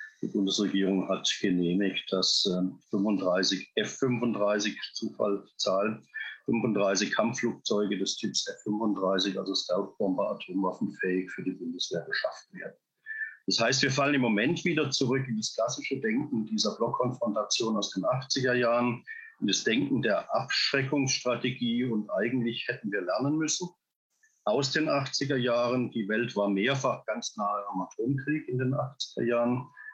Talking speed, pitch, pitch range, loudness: 135 wpm, 120 Hz, 100-135 Hz, -29 LUFS